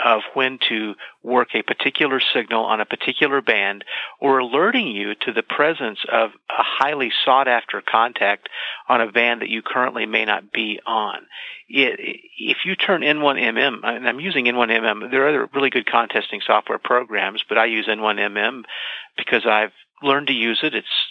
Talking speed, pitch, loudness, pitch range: 170 wpm, 130 Hz, -19 LUFS, 115-190 Hz